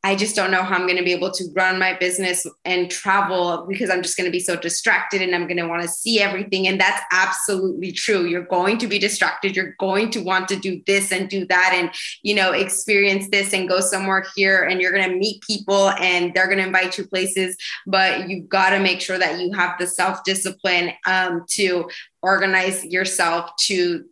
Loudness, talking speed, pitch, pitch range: -19 LUFS, 210 wpm, 185 Hz, 180-195 Hz